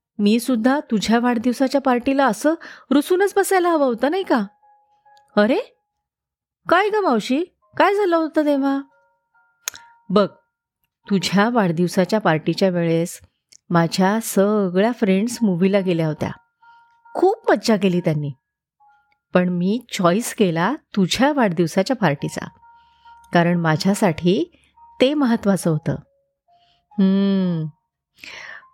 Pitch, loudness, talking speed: 235 Hz, -19 LUFS, 100 wpm